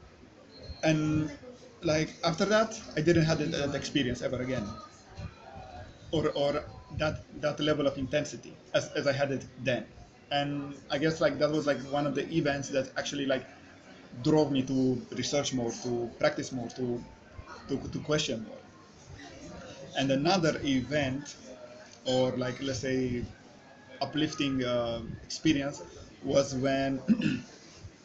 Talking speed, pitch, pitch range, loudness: 135 wpm, 140 Hz, 130-150 Hz, -31 LUFS